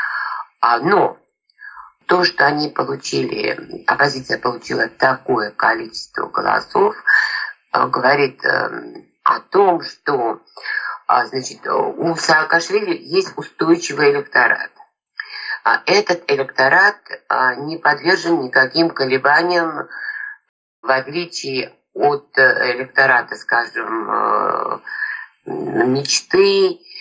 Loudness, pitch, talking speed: -17 LUFS, 335 Hz, 70 wpm